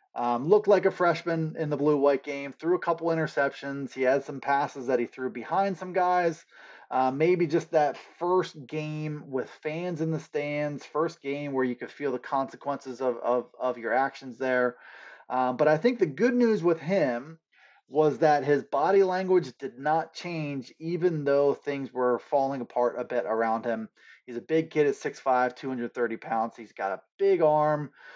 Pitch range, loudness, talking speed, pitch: 130-170 Hz, -27 LUFS, 190 wpm, 145 Hz